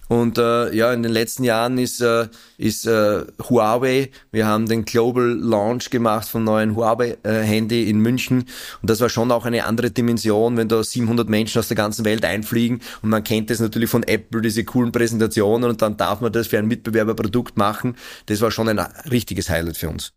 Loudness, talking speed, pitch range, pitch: -20 LUFS, 205 wpm, 110-120 Hz, 115 Hz